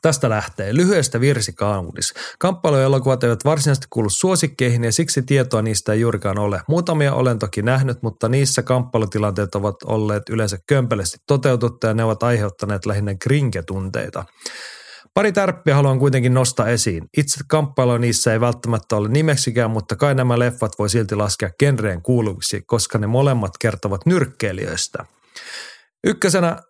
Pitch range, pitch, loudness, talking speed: 105-140 Hz, 120 Hz, -19 LUFS, 140 wpm